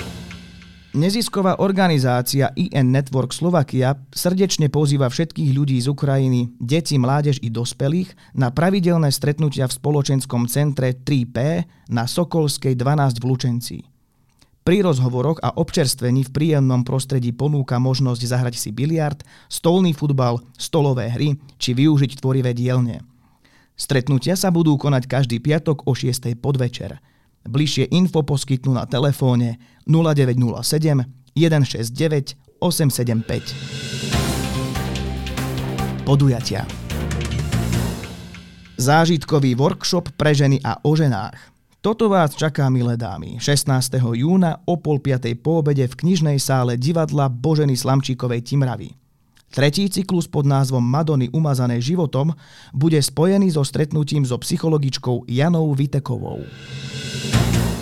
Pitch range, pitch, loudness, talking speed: 125-150 Hz, 135 Hz, -19 LUFS, 110 wpm